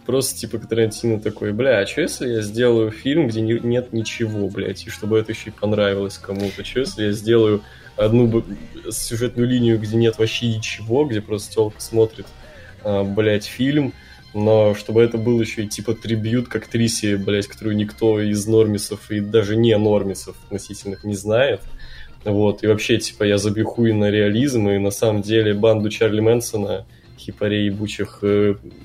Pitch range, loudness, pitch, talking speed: 105-115 Hz, -20 LUFS, 110 Hz, 175 wpm